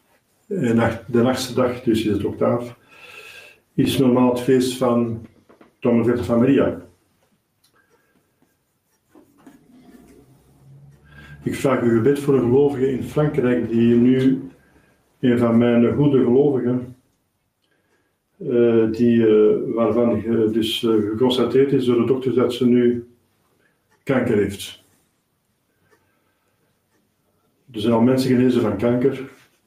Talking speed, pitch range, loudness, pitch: 115 wpm, 115-130 Hz, -19 LUFS, 120 Hz